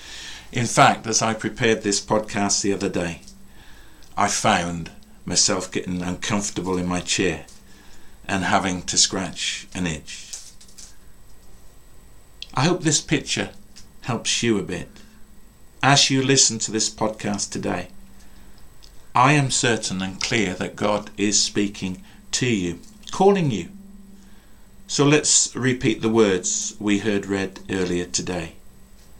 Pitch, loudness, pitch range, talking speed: 105 Hz, -21 LUFS, 95-120 Hz, 125 wpm